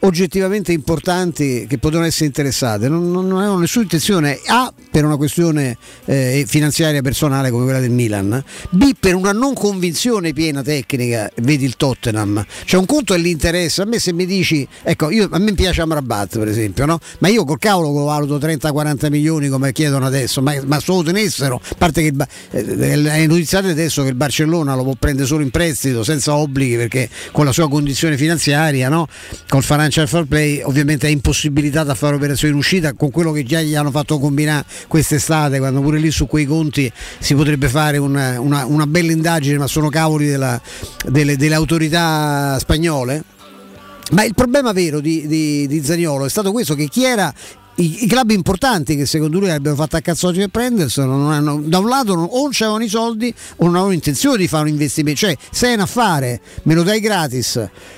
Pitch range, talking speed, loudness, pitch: 140-175 Hz, 195 wpm, -16 LUFS, 155 Hz